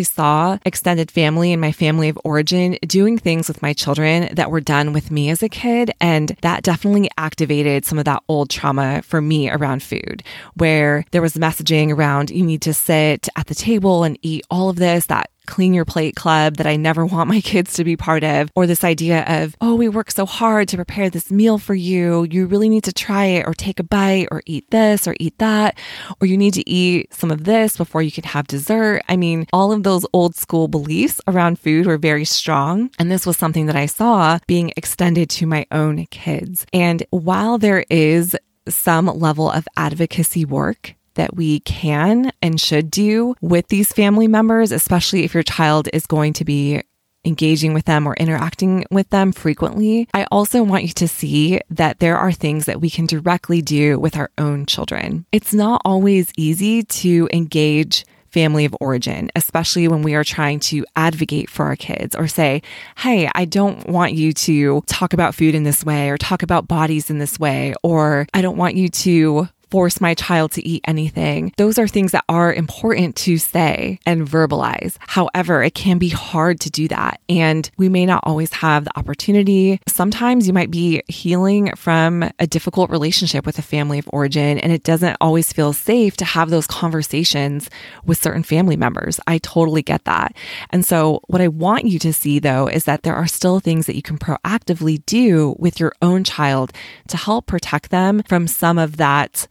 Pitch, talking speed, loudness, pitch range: 165 Hz, 200 wpm, -17 LUFS, 155-185 Hz